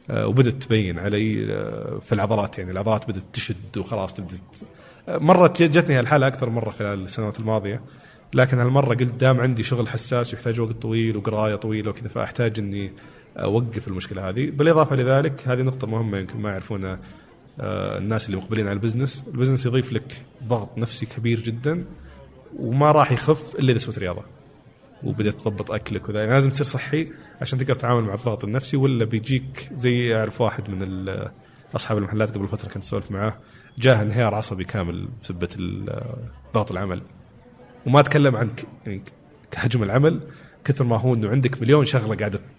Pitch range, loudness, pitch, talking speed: 105-130 Hz, -22 LUFS, 115 Hz, 160 wpm